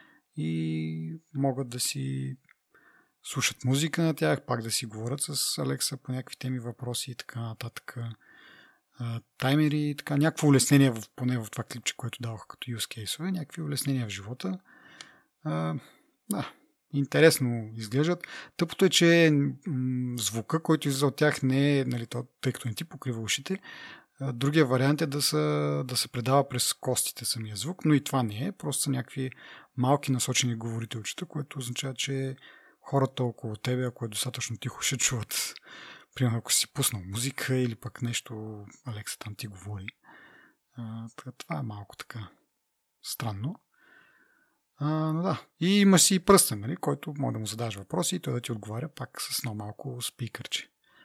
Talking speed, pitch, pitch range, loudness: 165 wpm, 130 Hz, 115-145 Hz, -28 LUFS